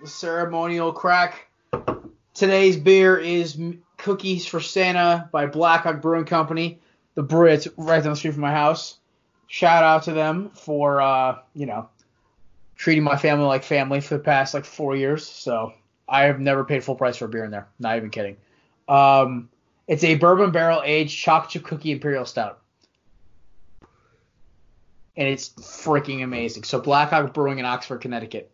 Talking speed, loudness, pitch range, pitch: 160 wpm, -21 LUFS, 135-165 Hz, 150 Hz